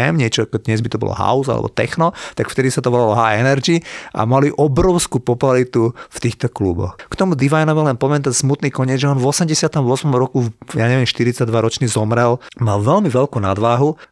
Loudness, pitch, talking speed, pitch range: -16 LUFS, 130 Hz, 185 wpm, 115-145 Hz